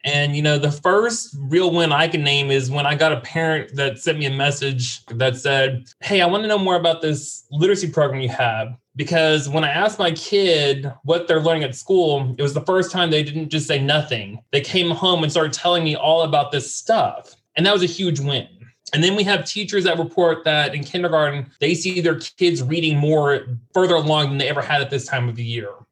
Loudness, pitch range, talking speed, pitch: -19 LUFS, 140-170 Hz, 235 wpm, 155 Hz